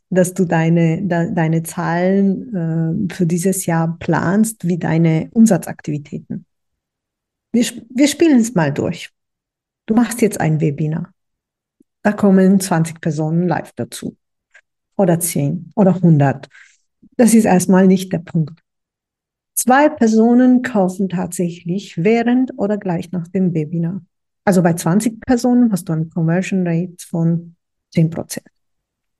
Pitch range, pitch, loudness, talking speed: 165-205 Hz, 185 Hz, -16 LUFS, 130 wpm